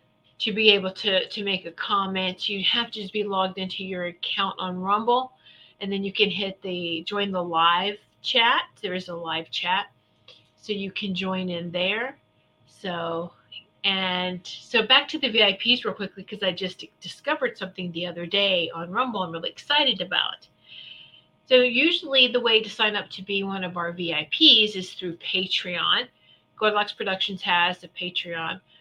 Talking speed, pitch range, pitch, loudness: 175 wpm, 180-210 Hz, 190 Hz, -23 LUFS